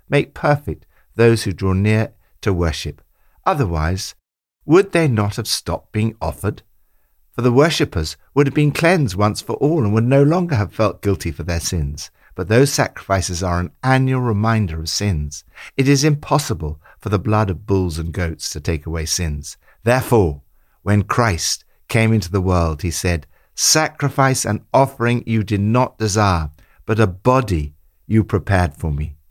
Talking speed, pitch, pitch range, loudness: 170 wpm, 105 Hz, 85-120 Hz, -18 LUFS